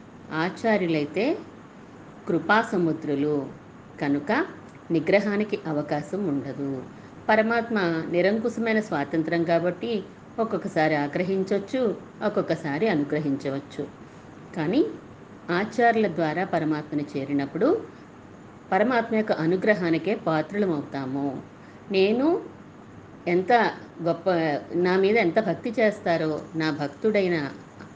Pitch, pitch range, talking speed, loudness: 175 Hz, 150-210 Hz, 70 wpm, -25 LUFS